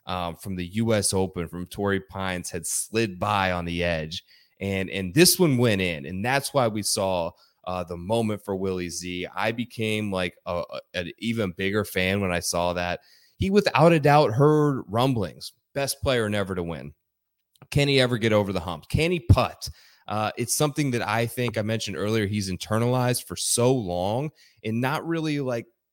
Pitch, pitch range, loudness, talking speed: 105 Hz, 90-125 Hz, -25 LUFS, 190 wpm